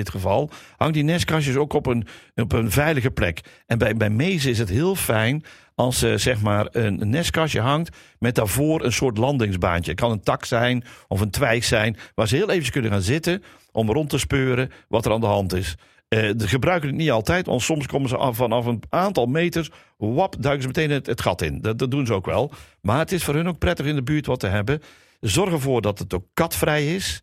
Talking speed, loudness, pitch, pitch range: 240 wpm, -22 LUFS, 125 Hz, 110-150 Hz